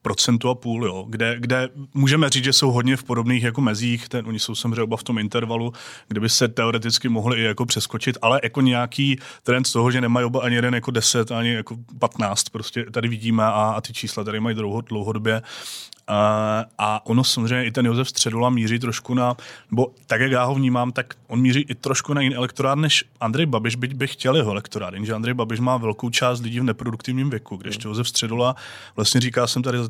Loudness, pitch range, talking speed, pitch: -21 LUFS, 115-130 Hz, 220 wpm, 120 Hz